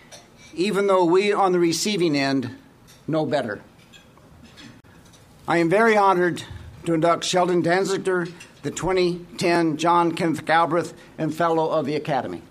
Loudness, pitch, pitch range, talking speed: -21 LUFS, 170 Hz, 155-180 Hz, 130 wpm